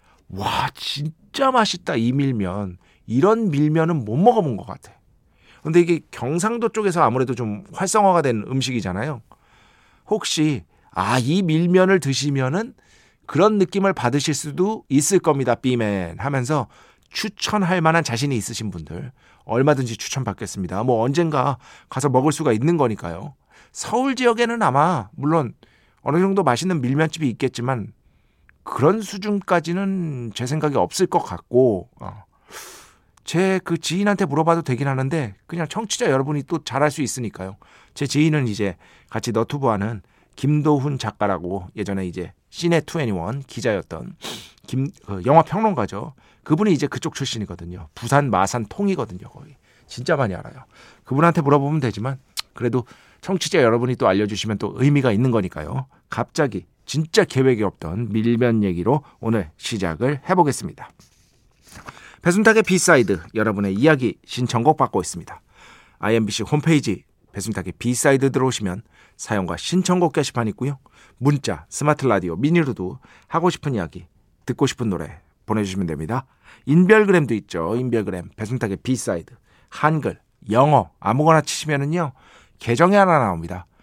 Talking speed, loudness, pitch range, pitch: 325 characters per minute, -21 LUFS, 110-165 Hz, 135 Hz